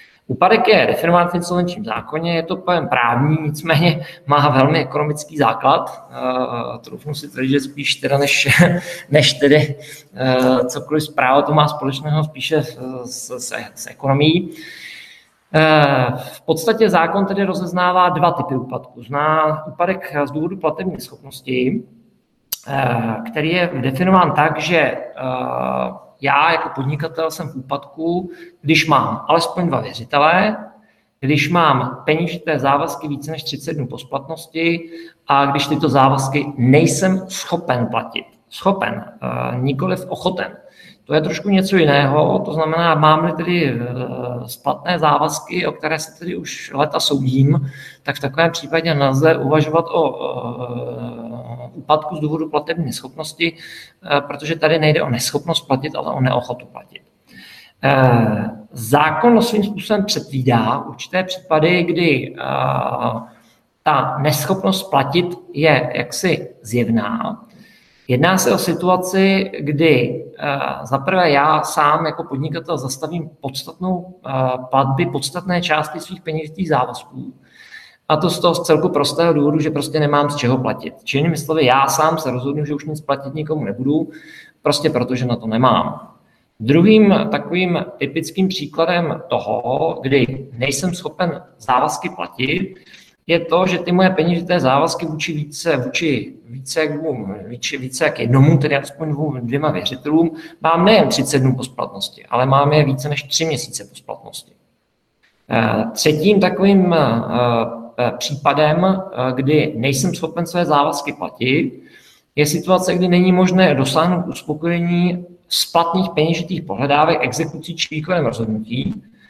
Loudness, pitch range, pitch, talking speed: -17 LUFS, 135-170 Hz, 155 Hz, 130 wpm